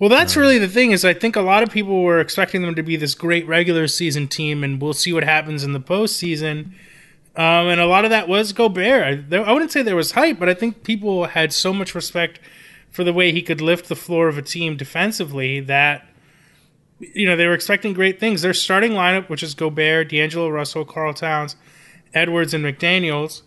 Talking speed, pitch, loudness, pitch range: 220 wpm, 170 Hz, -17 LUFS, 155-190 Hz